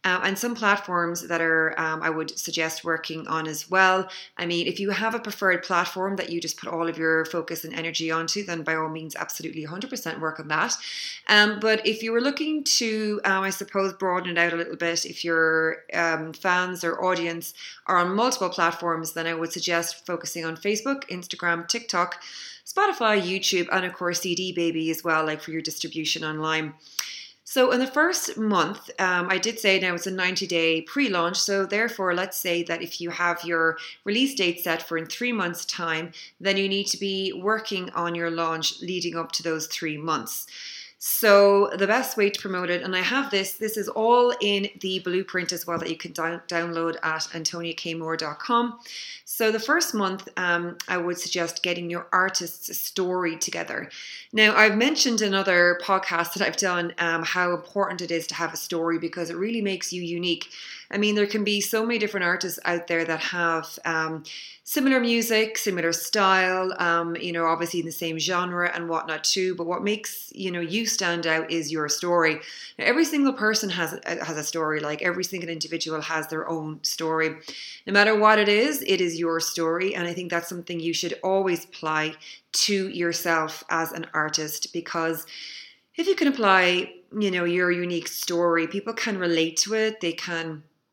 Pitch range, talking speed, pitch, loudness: 165-195 Hz, 195 wpm, 175 Hz, -24 LUFS